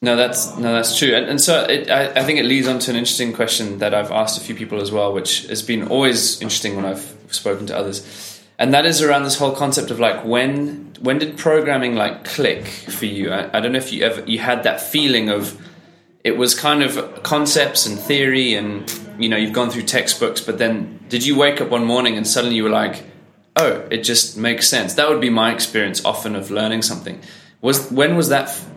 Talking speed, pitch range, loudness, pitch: 235 wpm, 110-135 Hz, -17 LUFS, 120 Hz